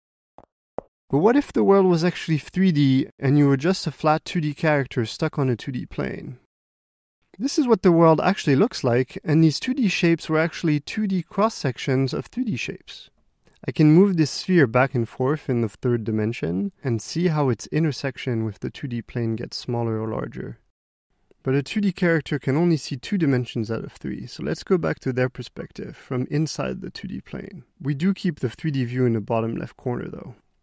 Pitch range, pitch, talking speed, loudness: 125-175 Hz, 150 Hz, 200 wpm, -23 LUFS